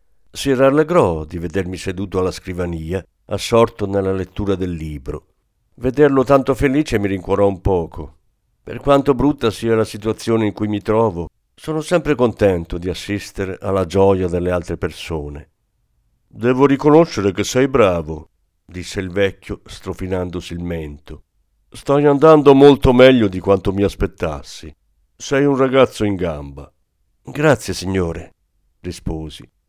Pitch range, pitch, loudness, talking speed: 90-125 Hz, 100 Hz, -17 LUFS, 135 wpm